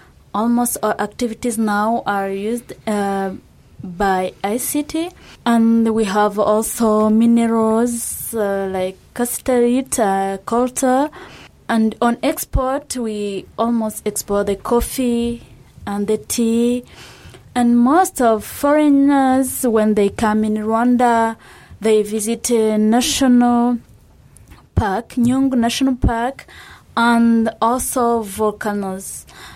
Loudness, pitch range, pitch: -17 LUFS, 215-245 Hz, 230 Hz